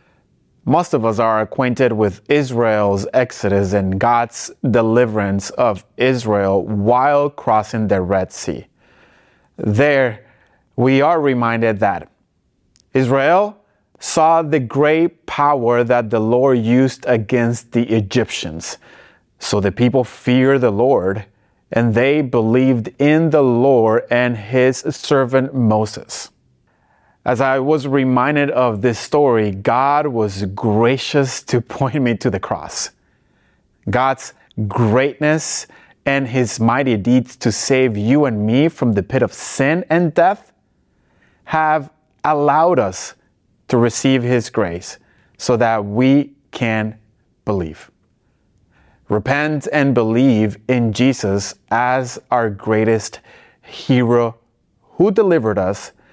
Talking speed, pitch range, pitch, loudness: 115 wpm, 110-135 Hz, 120 Hz, -16 LUFS